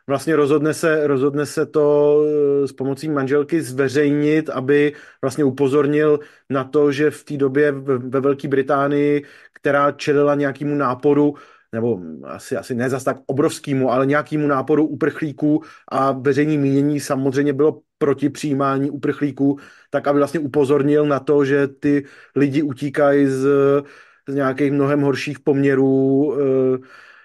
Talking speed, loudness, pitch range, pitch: 135 wpm, -18 LUFS, 140-145 Hz, 145 Hz